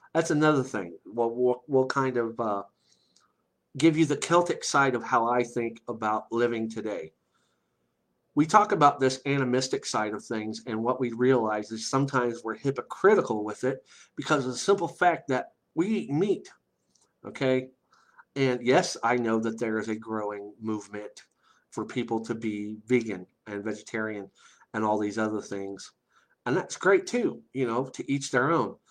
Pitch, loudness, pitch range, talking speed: 120 Hz, -27 LUFS, 110-130 Hz, 170 wpm